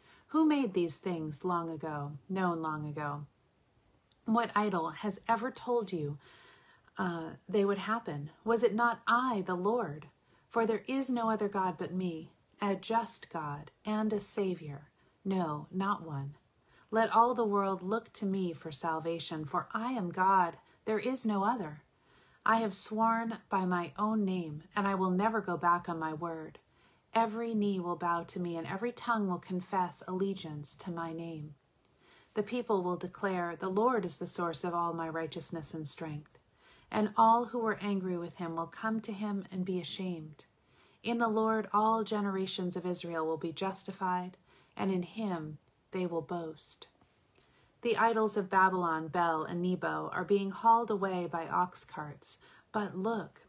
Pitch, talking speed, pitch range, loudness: 185 Hz, 170 wpm, 165-215 Hz, -33 LUFS